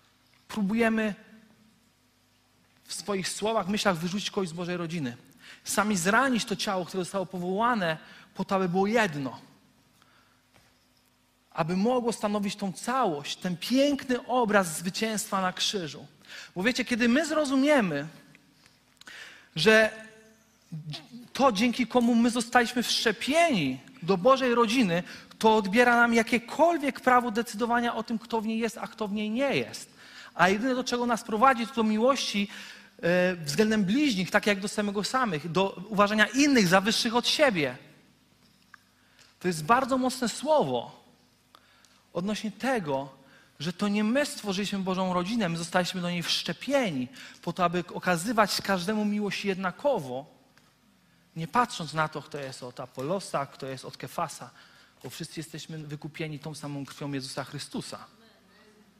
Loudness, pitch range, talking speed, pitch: -27 LUFS, 175-235 Hz, 140 wpm, 205 Hz